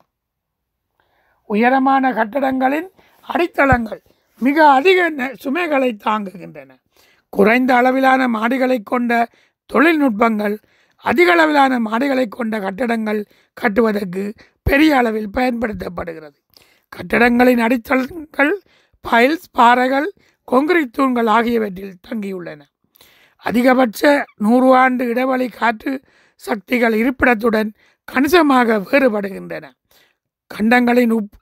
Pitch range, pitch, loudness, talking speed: 220-270 Hz, 250 Hz, -16 LUFS, 75 wpm